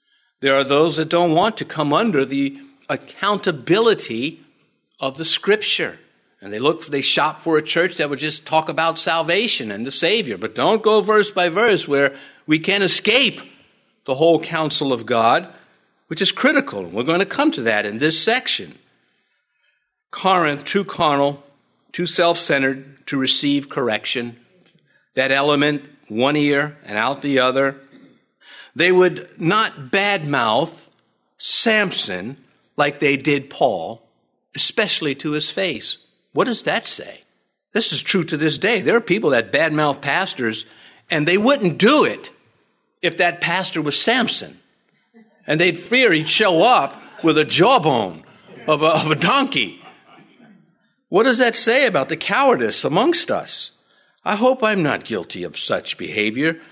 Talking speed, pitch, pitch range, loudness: 155 wpm, 165 Hz, 145-205 Hz, -18 LUFS